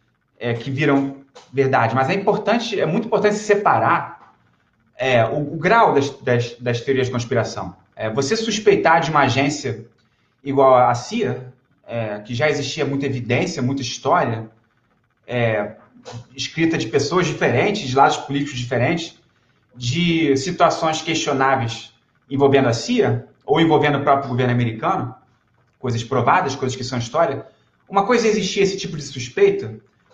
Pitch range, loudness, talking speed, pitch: 120-155 Hz, -19 LUFS, 145 wpm, 135 Hz